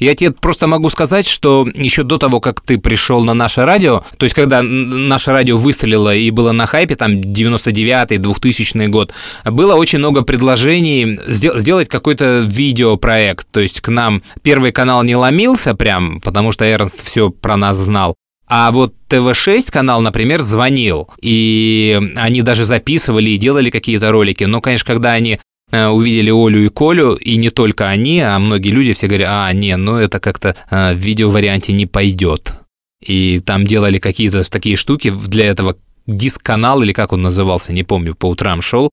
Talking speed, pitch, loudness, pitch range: 170 wpm, 110 Hz, -12 LUFS, 100-125 Hz